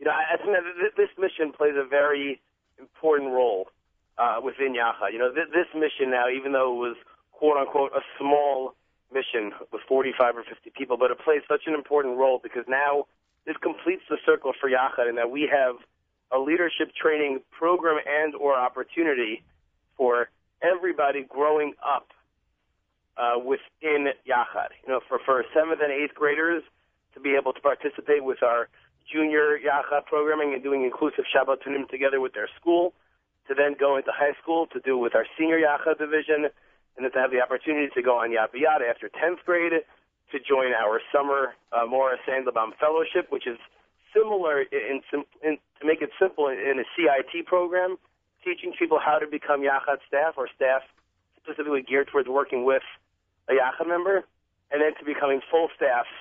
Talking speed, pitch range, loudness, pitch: 175 wpm, 130-160 Hz, -25 LUFS, 145 Hz